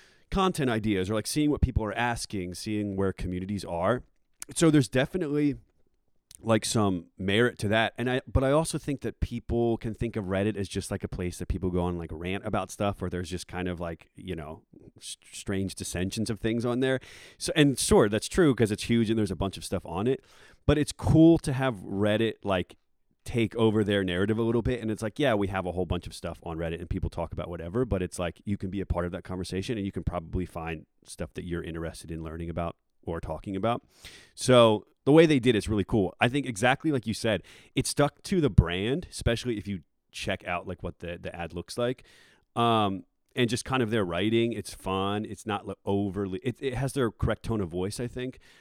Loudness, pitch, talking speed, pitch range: -28 LUFS, 105 Hz, 230 wpm, 90-120 Hz